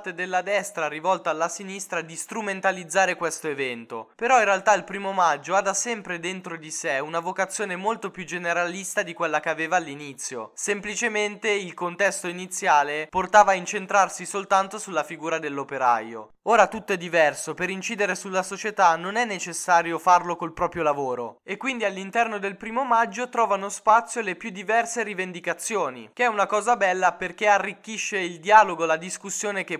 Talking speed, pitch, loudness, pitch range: 165 wpm, 190 Hz, -24 LUFS, 170-205 Hz